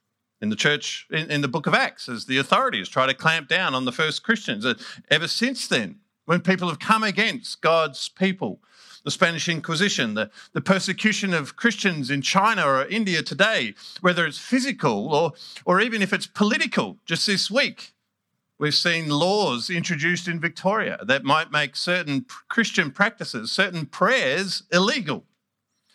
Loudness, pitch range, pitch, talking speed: -22 LUFS, 155-210 Hz, 180 Hz, 160 wpm